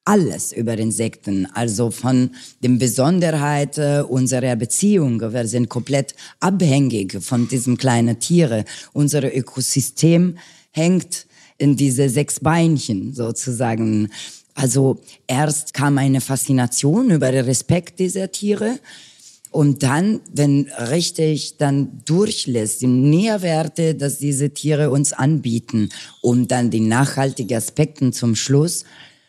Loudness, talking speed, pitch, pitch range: -18 LUFS, 115 wpm, 135 Hz, 125-155 Hz